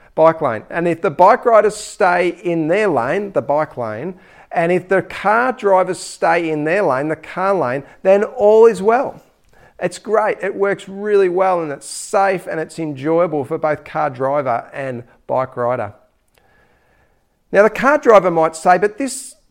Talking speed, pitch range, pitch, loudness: 175 wpm, 155-205 Hz, 180 Hz, -16 LUFS